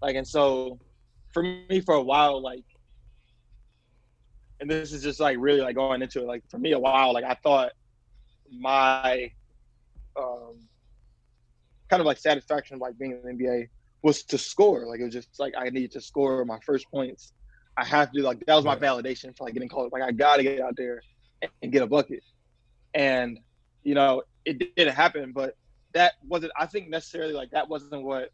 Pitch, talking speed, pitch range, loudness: 135 Hz, 195 wpm, 125-145 Hz, -26 LUFS